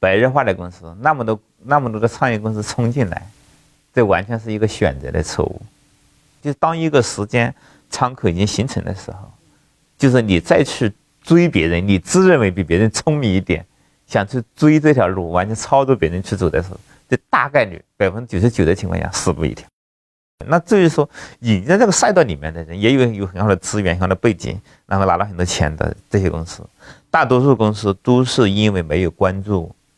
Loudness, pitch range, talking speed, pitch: -17 LUFS, 95-130 Hz, 305 characters per minute, 105 Hz